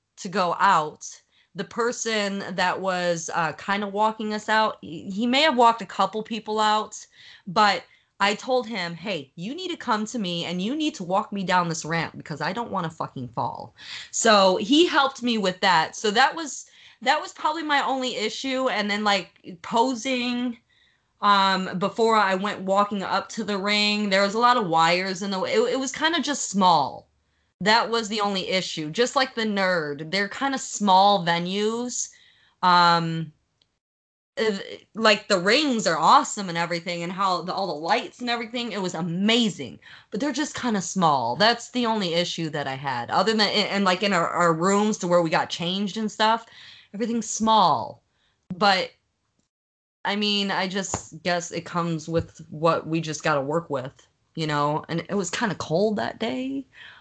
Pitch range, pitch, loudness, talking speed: 175-230 Hz, 205 Hz, -23 LUFS, 190 wpm